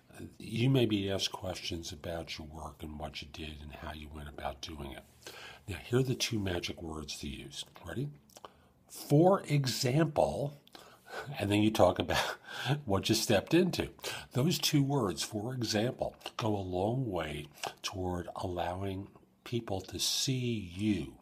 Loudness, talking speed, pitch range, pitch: -33 LUFS, 155 wpm, 80-120 Hz, 100 Hz